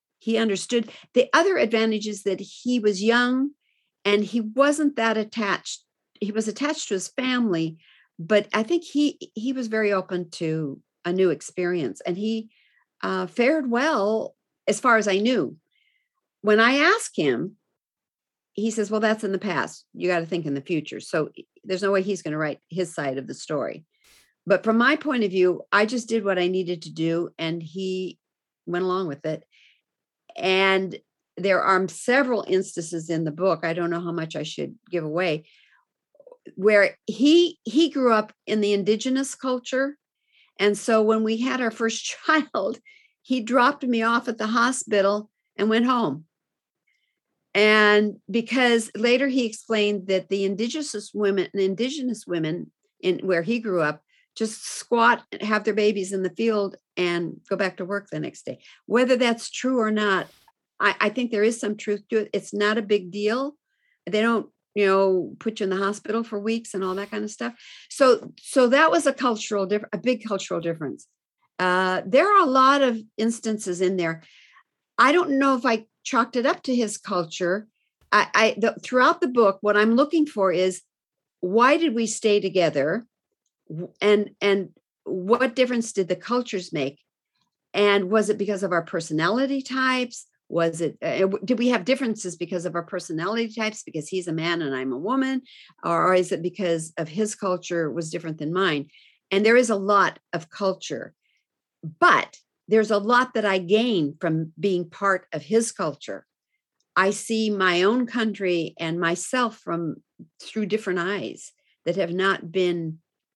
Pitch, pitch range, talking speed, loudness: 210 Hz, 185-240 Hz, 180 wpm, -23 LUFS